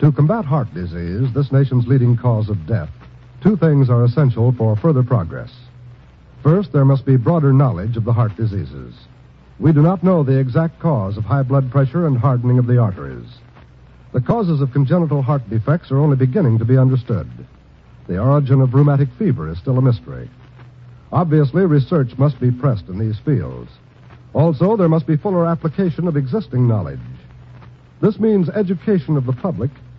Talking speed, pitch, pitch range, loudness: 175 wpm, 130 Hz, 120-150 Hz, -17 LUFS